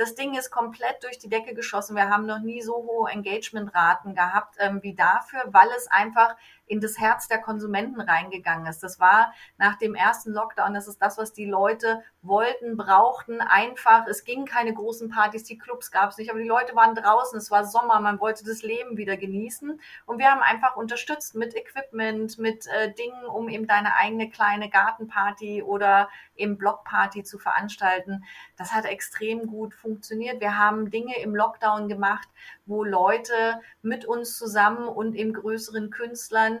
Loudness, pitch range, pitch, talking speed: -24 LUFS, 205-230 Hz, 220 Hz, 180 wpm